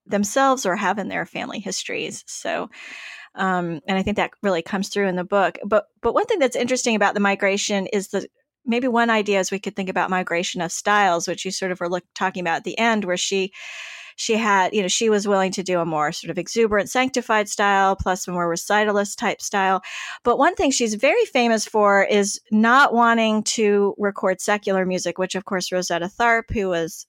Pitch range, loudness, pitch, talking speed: 185-220 Hz, -21 LUFS, 200 Hz, 215 wpm